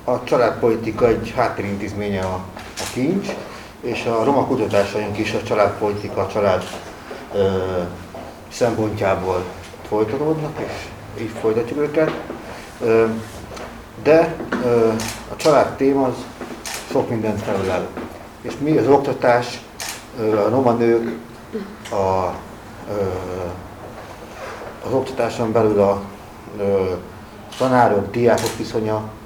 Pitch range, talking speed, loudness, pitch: 100-115 Hz, 90 wpm, -20 LUFS, 110 Hz